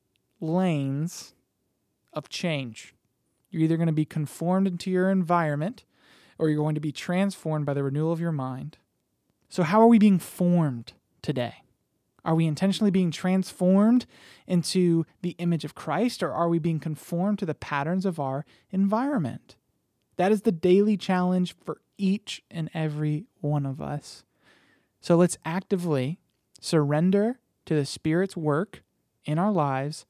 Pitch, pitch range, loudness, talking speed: 170 Hz, 150-185 Hz, -26 LUFS, 150 wpm